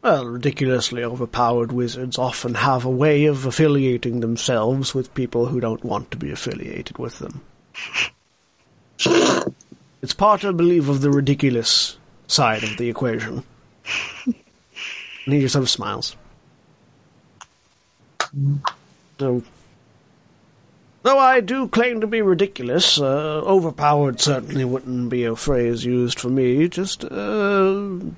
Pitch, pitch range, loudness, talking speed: 135 Hz, 120-160 Hz, -20 LUFS, 120 wpm